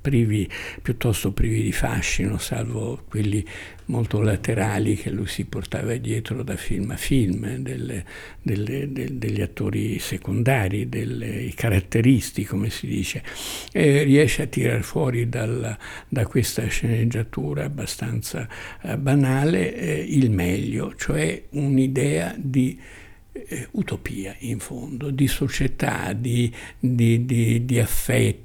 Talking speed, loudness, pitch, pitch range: 120 wpm, -24 LUFS, 115 Hz, 105-130 Hz